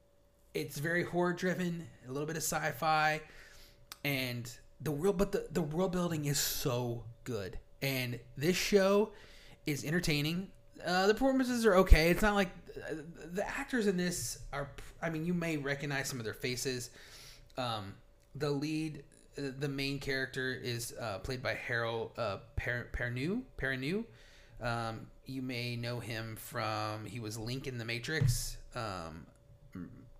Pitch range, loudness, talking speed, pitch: 115-160 Hz, -35 LUFS, 150 wpm, 140 Hz